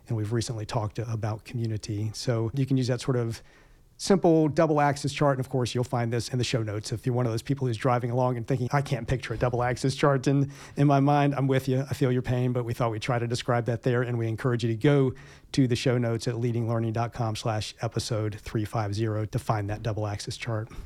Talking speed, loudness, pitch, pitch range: 245 wpm, -27 LUFS, 125 Hz, 115-135 Hz